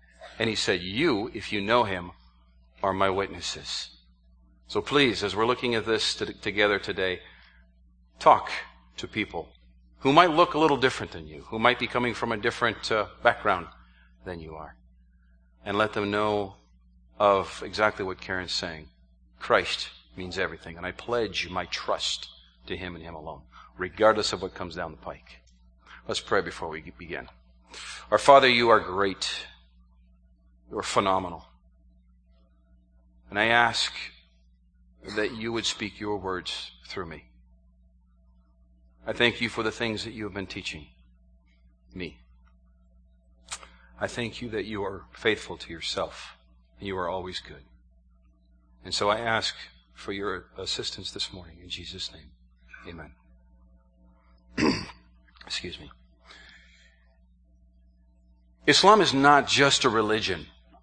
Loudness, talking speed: -26 LUFS, 140 wpm